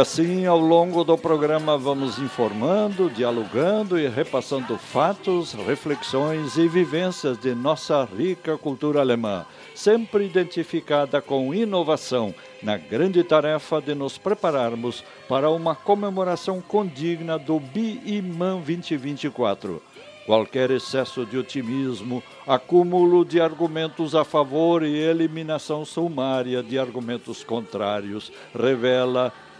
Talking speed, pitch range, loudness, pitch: 105 wpm, 130-175 Hz, -23 LUFS, 155 Hz